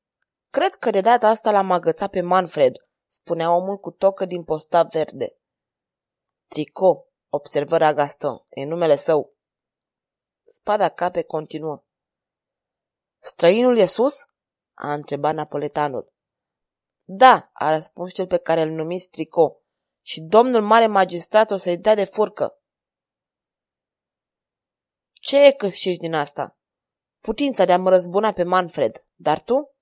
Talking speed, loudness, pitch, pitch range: 125 wpm, -20 LUFS, 180 Hz, 160-215 Hz